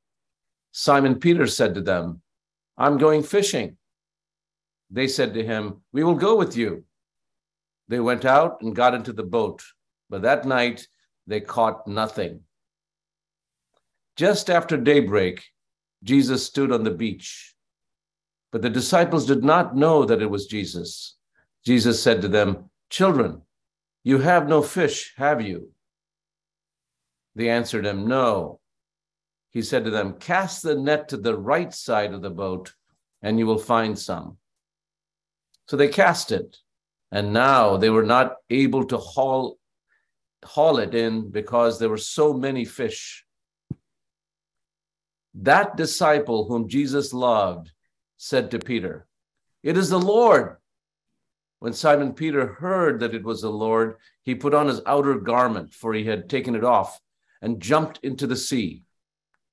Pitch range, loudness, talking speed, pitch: 110-150 Hz, -22 LUFS, 145 wpm, 125 Hz